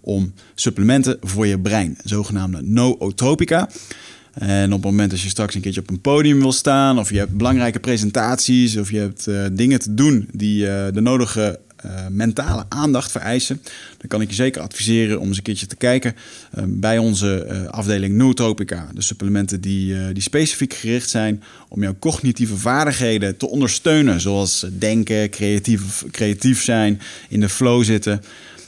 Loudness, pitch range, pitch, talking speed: -18 LUFS, 100-125 Hz, 105 Hz, 170 wpm